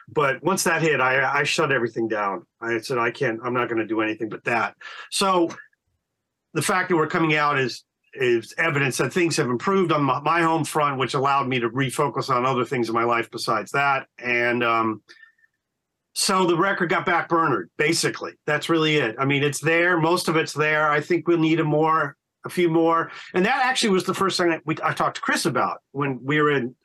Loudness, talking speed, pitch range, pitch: -22 LUFS, 225 wpm, 135-175 Hz, 155 Hz